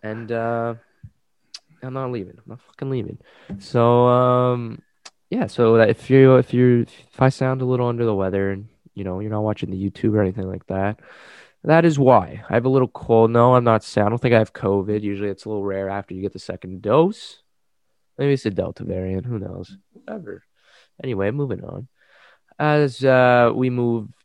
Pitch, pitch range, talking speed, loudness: 115 Hz, 100-125 Hz, 200 wpm, -19 LUFS